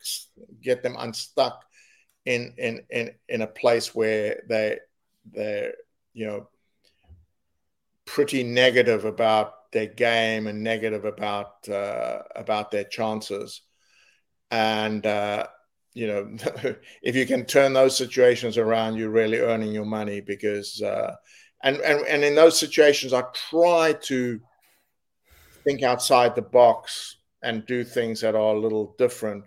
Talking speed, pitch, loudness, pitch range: 130 wpm, 115 Hz, -23 LUFS, 105-130 Hz